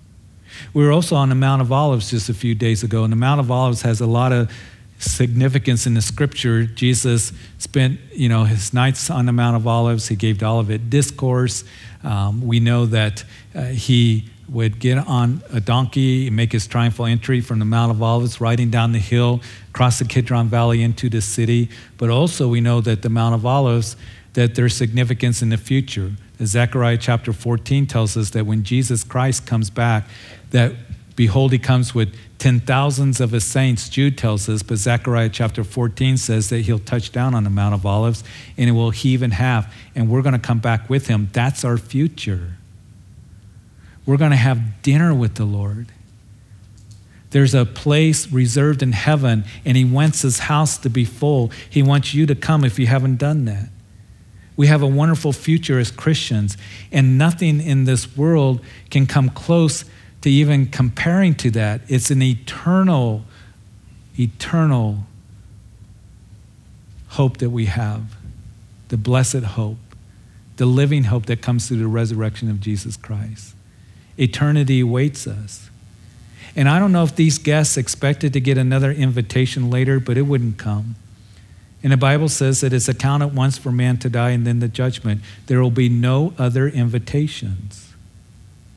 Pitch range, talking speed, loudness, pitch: 110-130 Hz, 175 wpm, -18 LUFS, 120 Hz